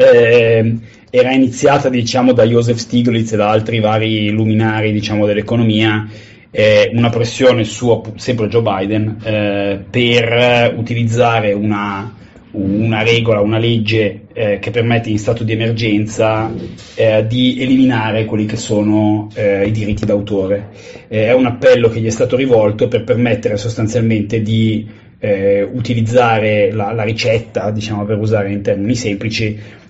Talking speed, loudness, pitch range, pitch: 140 wpm, -14 LUFS, 105-115 Hz, 110 Hz